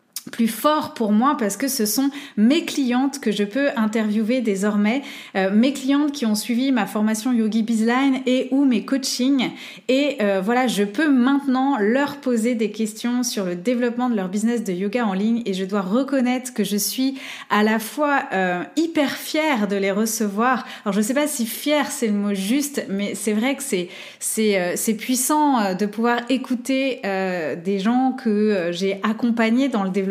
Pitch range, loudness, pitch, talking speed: 210-270 Hz, -21 LUFS, 235 Hz, 190 wpm